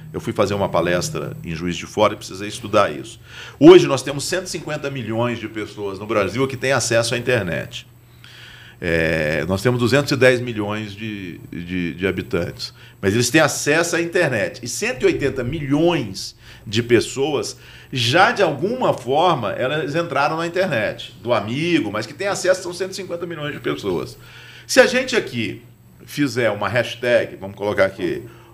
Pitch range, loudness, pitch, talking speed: 105-150 Hz, -19 LUFS, 125 Hz, 160 wpm